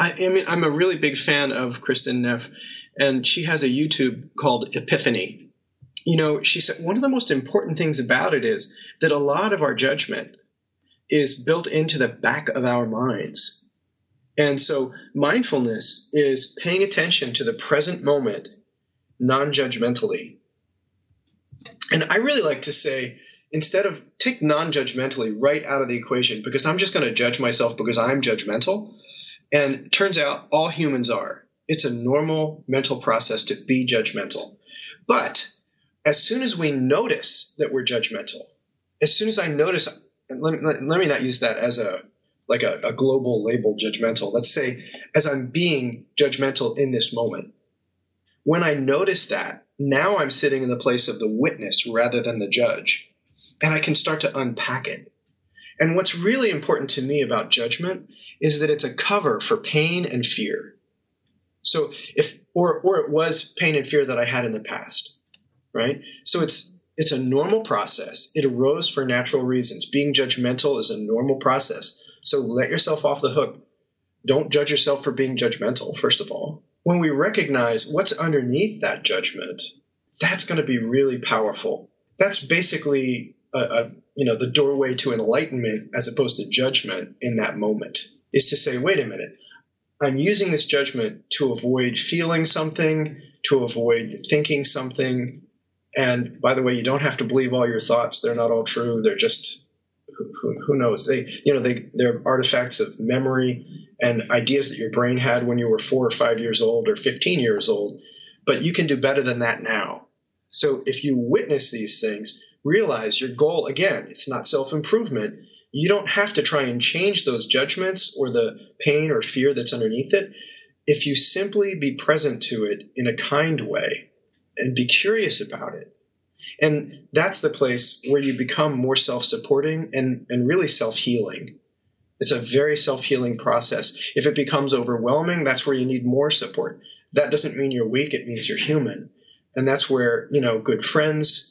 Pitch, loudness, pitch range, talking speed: 145 Hz, -20 LUFS, 130-170 Hz, 175 wpm